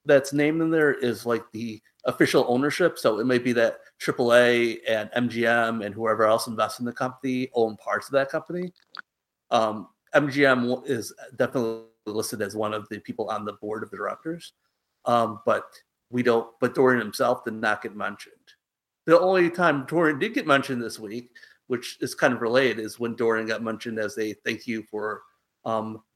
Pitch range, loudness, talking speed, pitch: 110-130 Hz, -25 LUFS, 185 wpm, 115 Hz